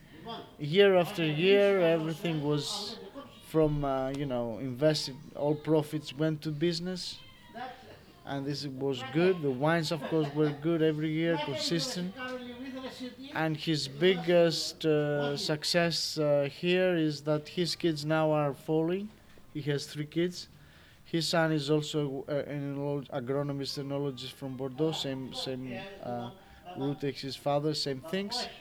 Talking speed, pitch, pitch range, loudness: 135 wpm, 155 Hz, 140-170 Hz, -30 LUFS